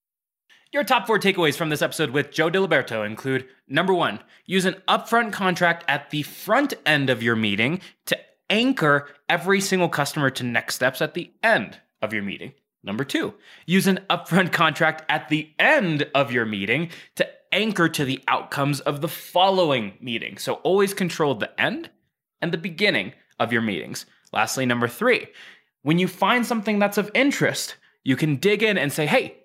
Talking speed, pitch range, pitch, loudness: 175 wpm, 140-190 Hz, 160 Hz, -22 LUFS